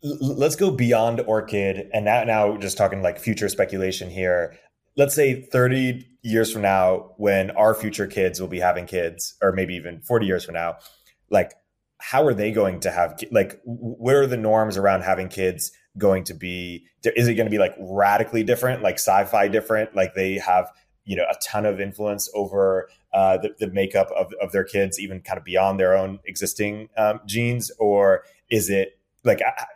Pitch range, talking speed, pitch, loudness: 95-110 Hz, 190 wpm, 100 Hz, -22 LUFS